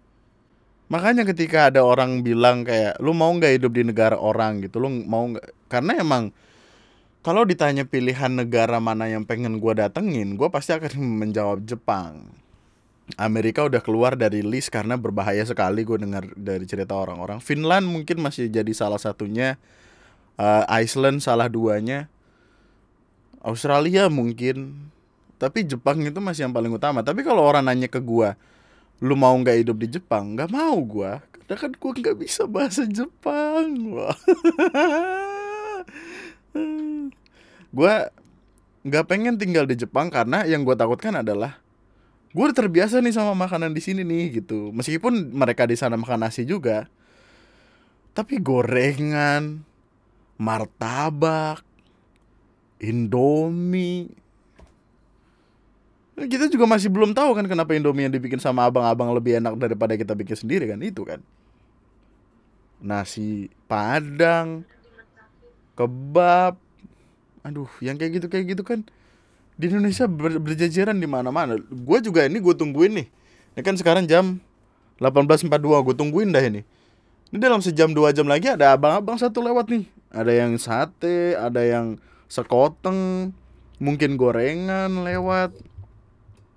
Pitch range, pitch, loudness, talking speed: 115-180 Hz, 135 Hz, -21 LUFS, 130 wpm